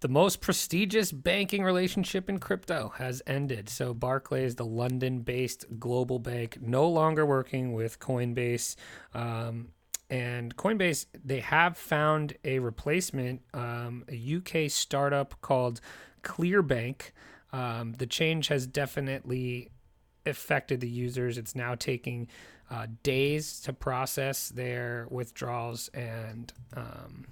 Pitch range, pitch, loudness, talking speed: 120-150 Hz, 130 Hz, -31 LUFS, 120 wpm